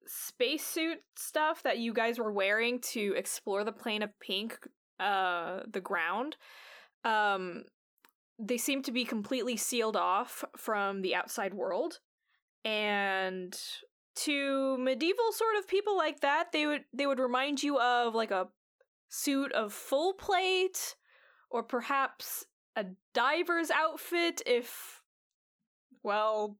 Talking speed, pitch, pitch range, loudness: 125 wpm, 255 Hz, 215-320 Hz, -32 LUFS